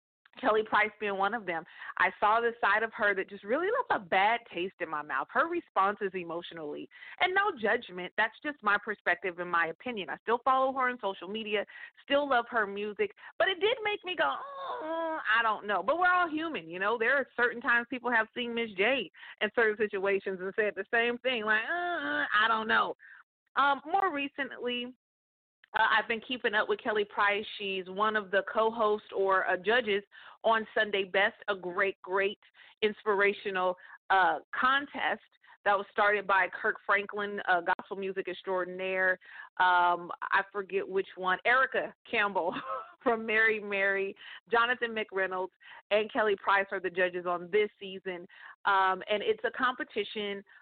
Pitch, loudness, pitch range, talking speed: 210 Hz, -30 LUFS, 195-245 Hz, 175 wpm